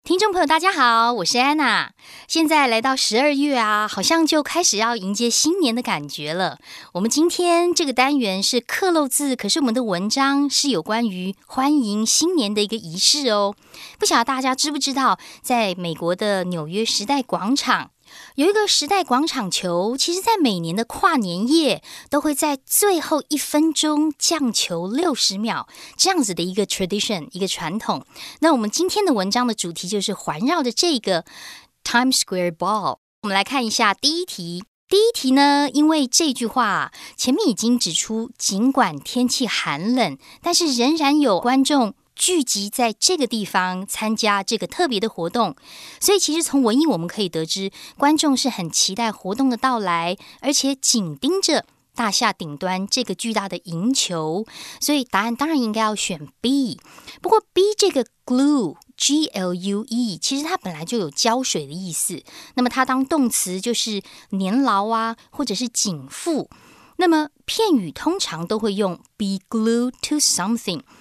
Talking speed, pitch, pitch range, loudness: 285 characters per minute, 245 Hz, 200-295 Hz, -20 LUFS